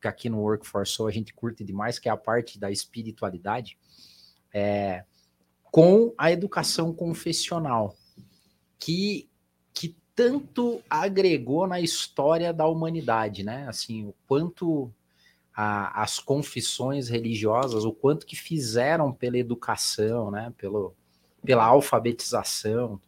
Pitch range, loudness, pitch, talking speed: 105-160 Hz, -26 LUFS, 120 Hz, 120 wpm